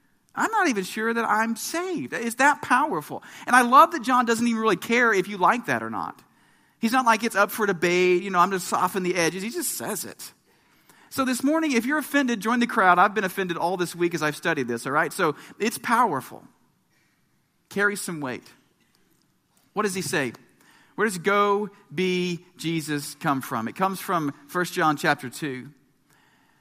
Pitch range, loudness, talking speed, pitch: 170-230 Hz, -23 LUFS, 200 wpm, 195 Hz